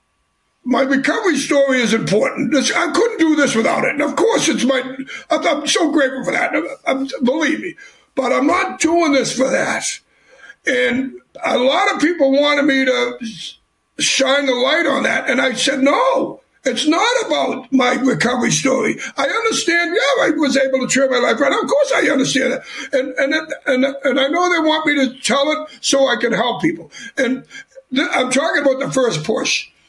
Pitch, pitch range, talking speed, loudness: 270 Hz, 255-310 Hz, 185 wpm, -16 LUFS